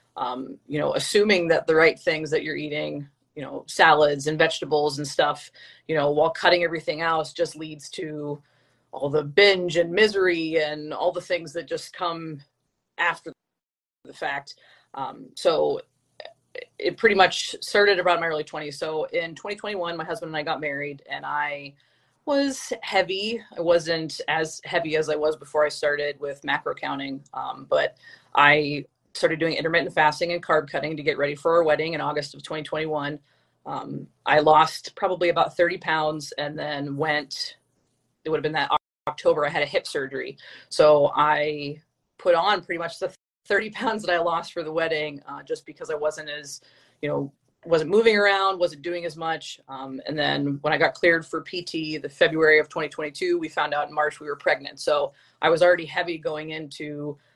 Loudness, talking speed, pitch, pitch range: -24 LUFS, 185 wpm, 160 Hz, 150-175 Hz